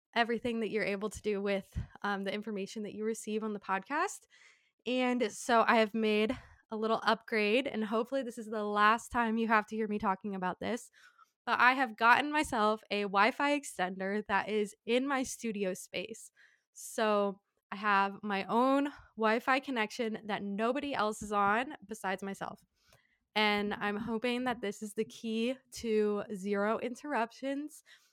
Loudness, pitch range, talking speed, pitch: -32 LUFS, 205-240 Hz, 170 wpm, 220 Hz